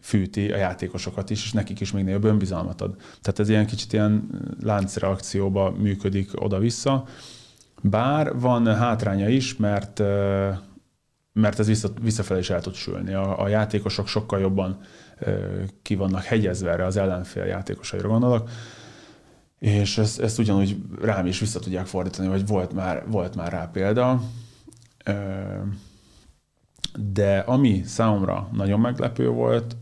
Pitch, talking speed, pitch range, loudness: 100 Hz, 135 wpm, 95-110 Hz, -24 LUFS